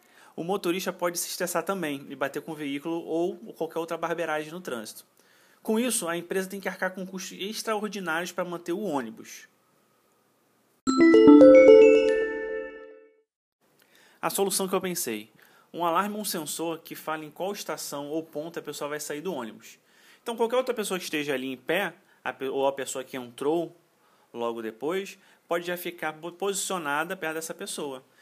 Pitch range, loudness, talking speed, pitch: 155-195 Hz, -25 LUFS, 165 wpm, 170 Hz